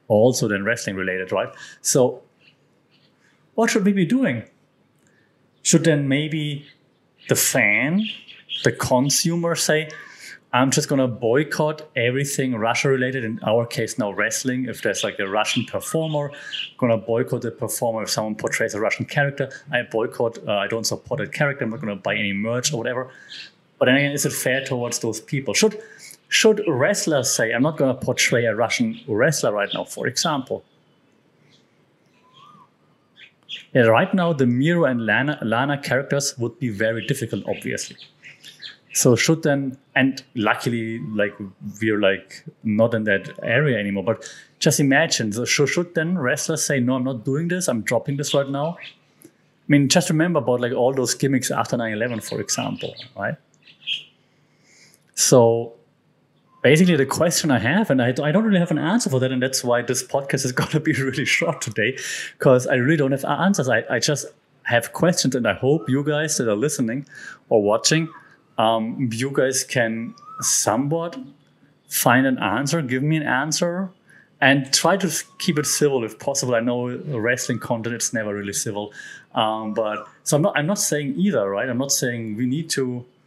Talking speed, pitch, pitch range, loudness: 170 wpm, 135 Hz, 120-155 Hz, -21 LUFS